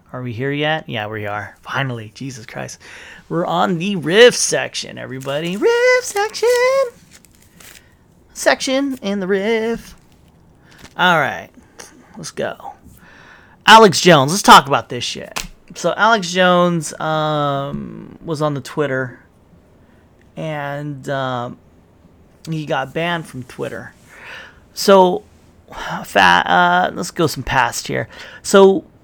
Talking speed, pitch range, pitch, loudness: 120 wpm, 130-195 Hz, 155 Hz, -15 LUFS